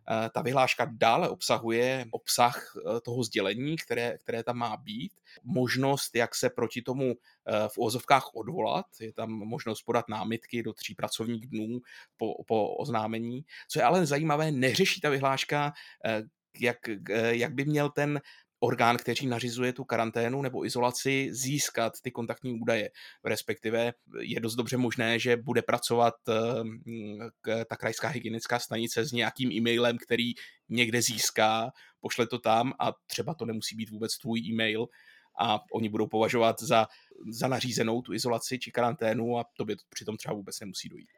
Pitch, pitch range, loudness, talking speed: 120 Hz, 115-125 Hz, -30 LUFS, 150 wpm